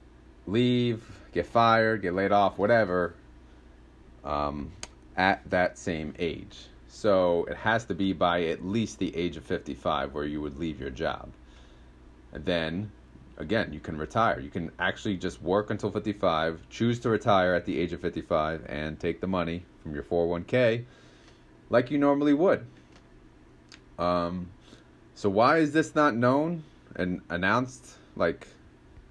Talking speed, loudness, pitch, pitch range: 150 wpm, -28 LUFS, 85 Hz, 70-110 Hz